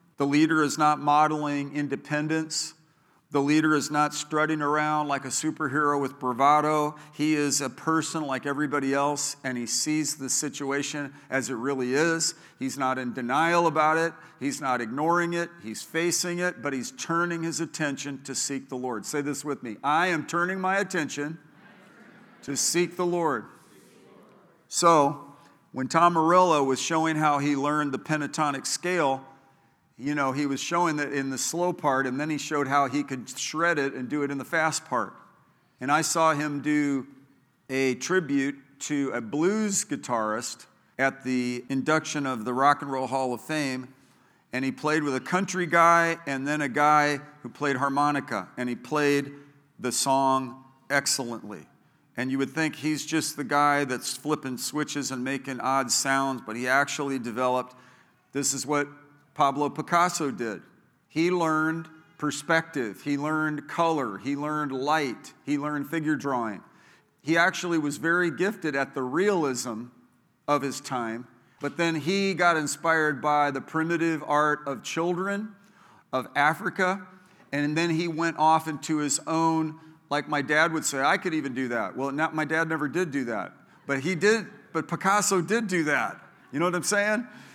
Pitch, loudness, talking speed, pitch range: 145 Hz, -26 LUFS, 170 wpm, 135-160 Hz